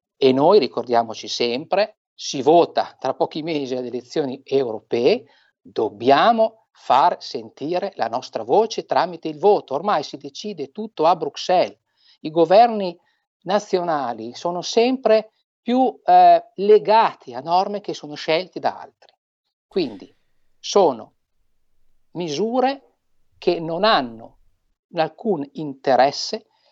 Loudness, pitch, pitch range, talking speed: -20 LUFS, 175 Hz, 140-215 Hz, 110 wpm